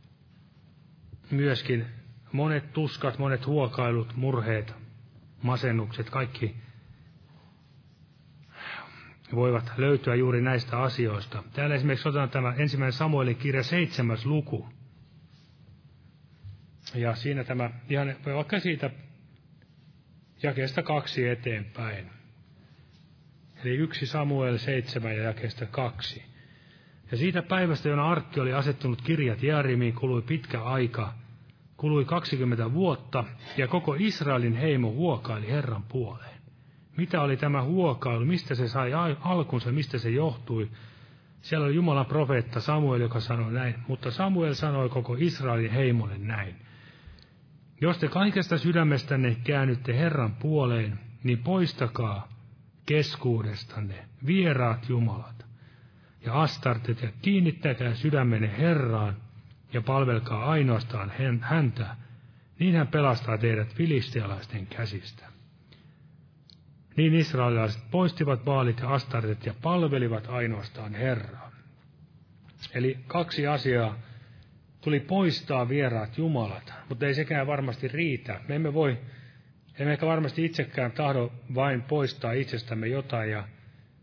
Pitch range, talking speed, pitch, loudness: 120-150 Hz, 105 wpm, 130 Hz, -28 LUFS